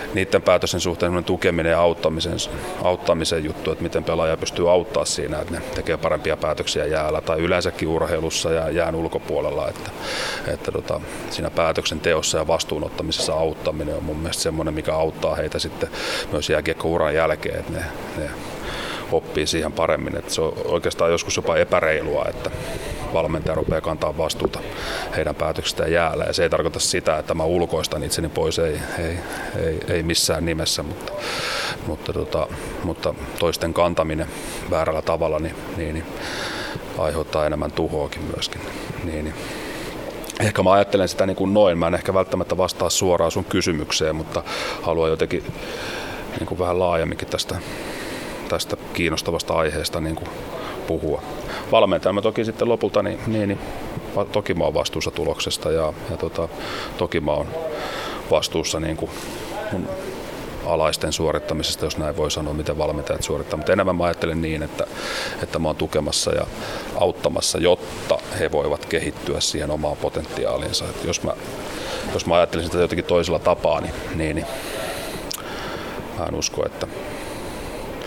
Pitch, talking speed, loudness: 90 Hz, 150 wpm, -23 LUFS